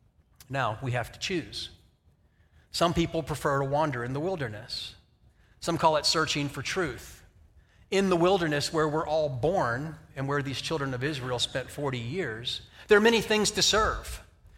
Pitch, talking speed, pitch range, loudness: 135 Hz, 170 wpm, 110-160 Hz, -28 LUFS